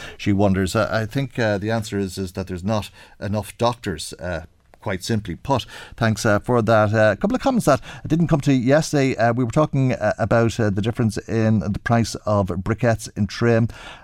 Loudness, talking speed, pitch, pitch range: -21 LUFS, 205 wpm, 110 Hz, 100-120 Hz